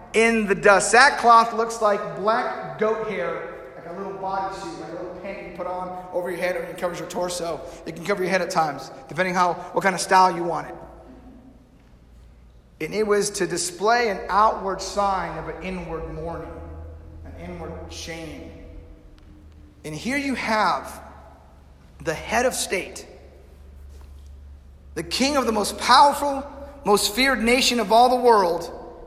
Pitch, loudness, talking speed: 180 Hz, -21 LUFS, 165 wpm